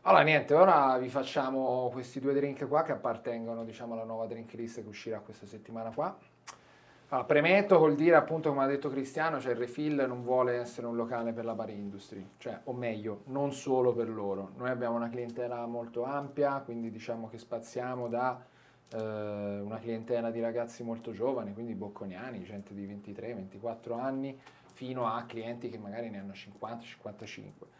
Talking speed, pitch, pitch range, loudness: 175 wpm, 120 Hz, 115-130 Hz, -32 LUFS